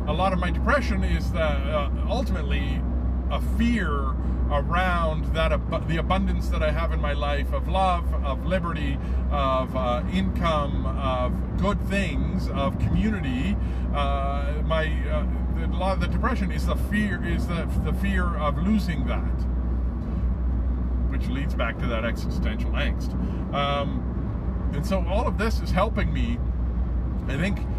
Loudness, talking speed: -26 LUFS, 155 wpm